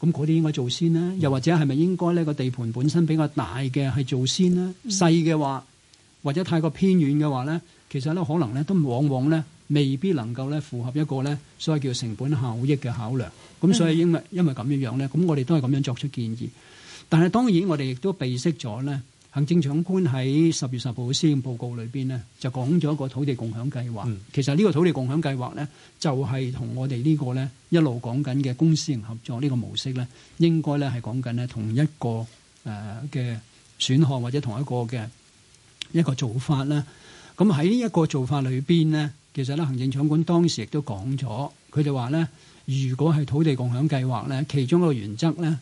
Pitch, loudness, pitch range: 140 Hz, -24 LUFS, 130-160 Hz